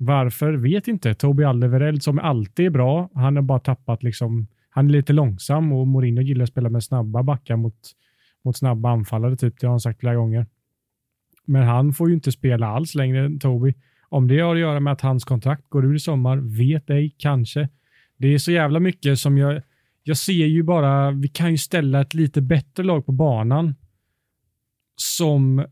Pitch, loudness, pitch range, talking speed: 135 Hz, -20 LUFS, 125-145 Hz, 200 wpm